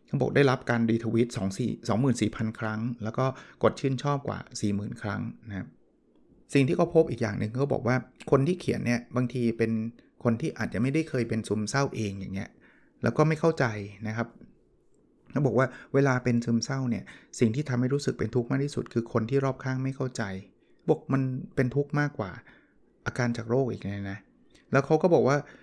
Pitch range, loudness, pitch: 115-135 Hz, -28 LUFS, 120 Hz